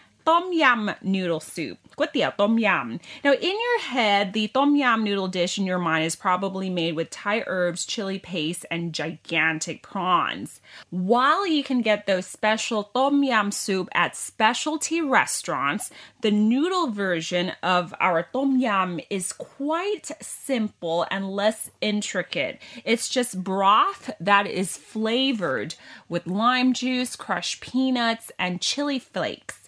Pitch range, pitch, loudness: 180-260 Hz, 215 Hz, -24 LUFS